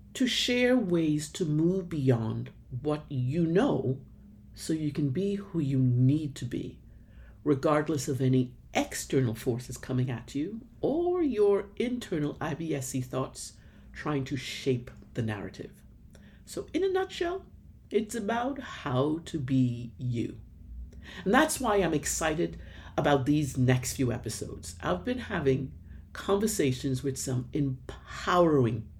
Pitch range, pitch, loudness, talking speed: 125-175 Hz, 140 Hz, -29 LUFS, 130 wpm